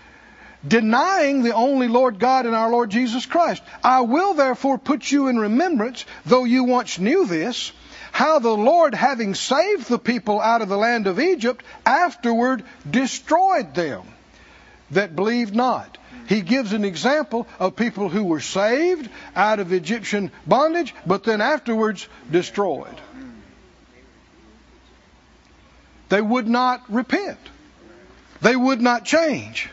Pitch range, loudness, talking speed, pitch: 215-270 Hz, -20 LUFS, 135 wpm, 245 Hz